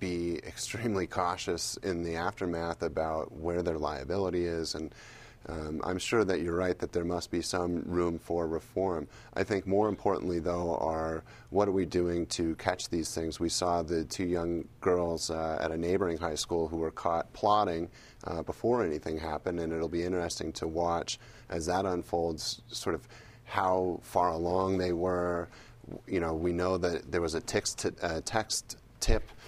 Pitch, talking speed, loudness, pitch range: 85 Hz, 180 wpm, -32 LUFS, 85-95 Hz